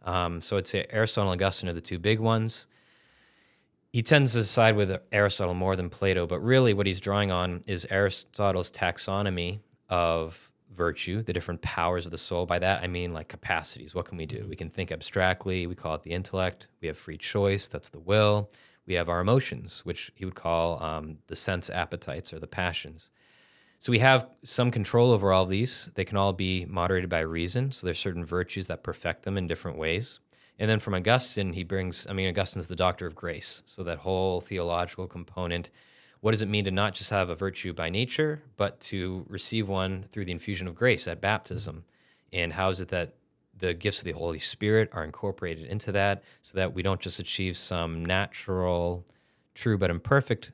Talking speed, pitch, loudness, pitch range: 200 wpm, 95 Hz, -28 LUFS, 90-105 Hz